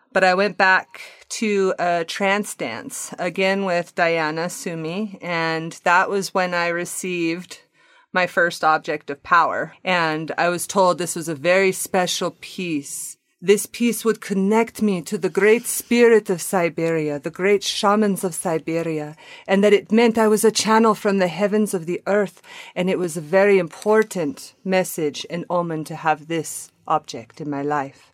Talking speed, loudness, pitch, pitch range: 170 wpm, -20 LUFS, 185 Hz, 165-205 Hz